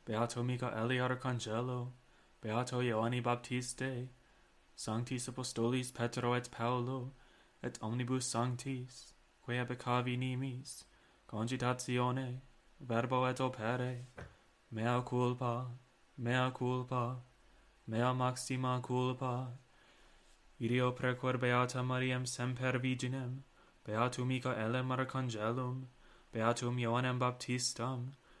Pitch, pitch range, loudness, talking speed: 125 Hz, 120-125 Hz, -37 LUFS, 90 wpm